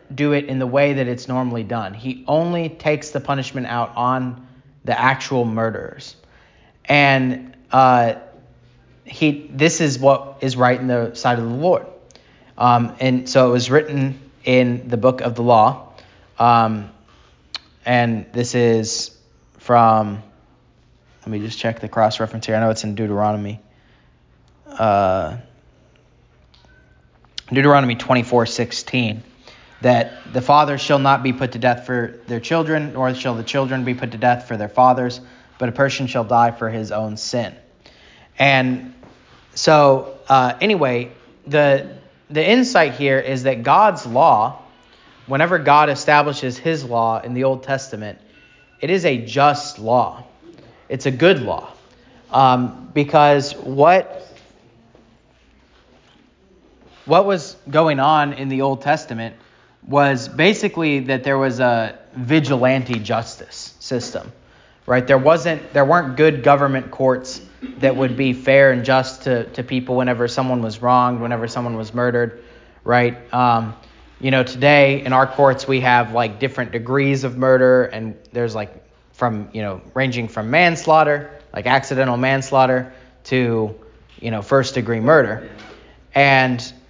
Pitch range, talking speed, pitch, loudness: 120-140 Hz, 145 wpm, 130 Hz, -17 LUFS